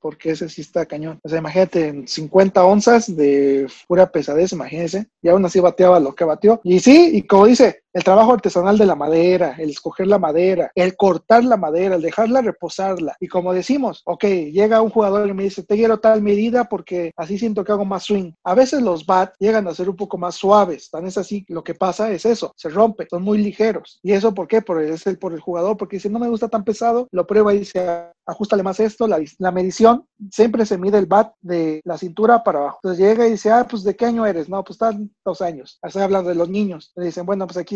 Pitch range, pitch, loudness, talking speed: 175-215 Hz, 195 Hz, -17 LUFS, 240 wpm